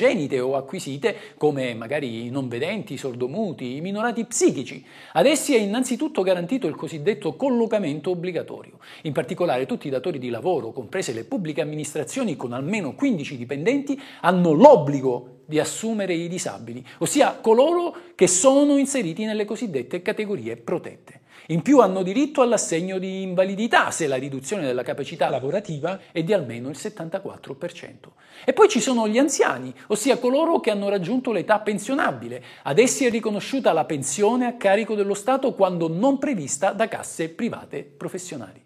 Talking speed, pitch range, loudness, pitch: 155 wpm, 150-235 Hz, -22 LUFS, 190 Hz